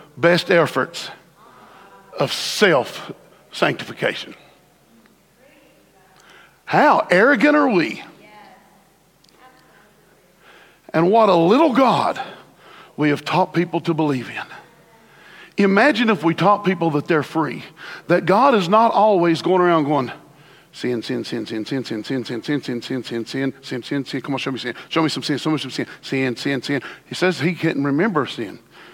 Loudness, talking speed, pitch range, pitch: -19 LUFS, 160 wpm, 135-185 Hz, 155 Hz